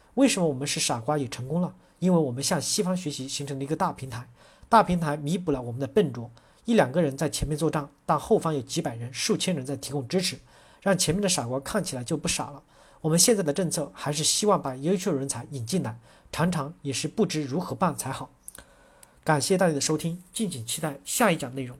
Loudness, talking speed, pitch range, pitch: -26 LUFS, 340 characters per minute, 140-180 Hz, 155 Hz